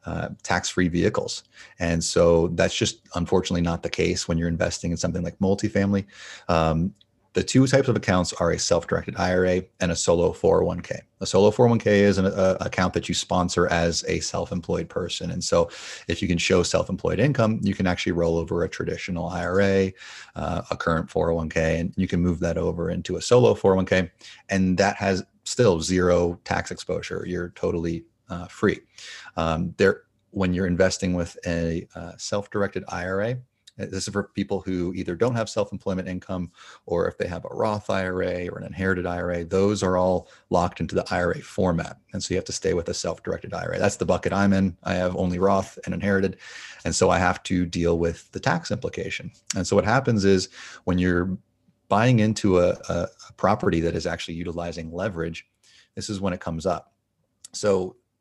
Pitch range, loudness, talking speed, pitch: 85-100 Hz, -24 LUFS, 195 wpm, 95 Hz